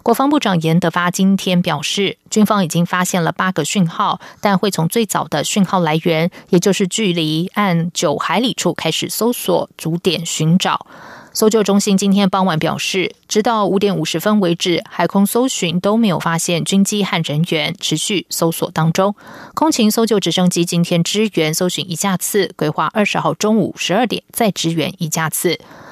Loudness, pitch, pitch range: -16 LUFS, 180 Hz, 165-205 Hz